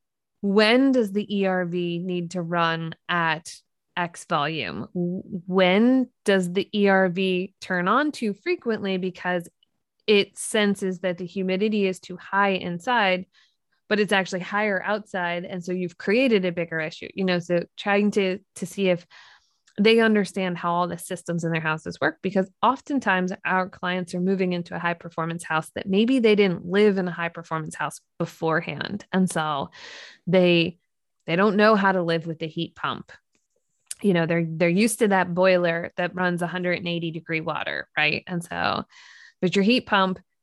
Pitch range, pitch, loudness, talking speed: 175-205 Hz, 185 Hz, -24 LUFS, 170 wpm